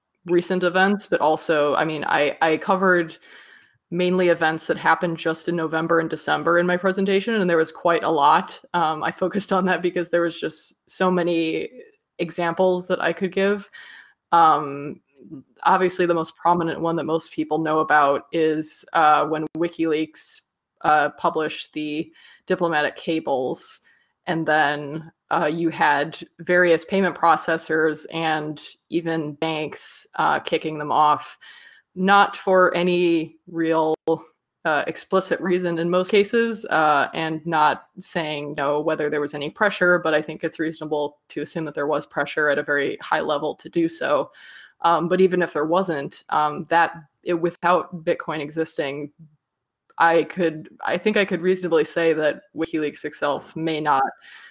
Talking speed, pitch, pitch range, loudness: 160 wpm, 165 Hz, 155-180 Hz, -22 LUFS